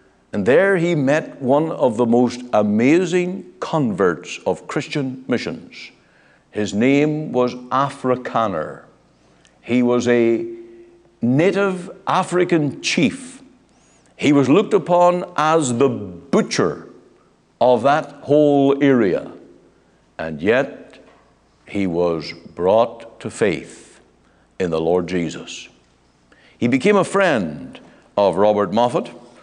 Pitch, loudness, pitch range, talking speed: 130 Hz, -18 LUFS, 115-170 Hz, 105 wpm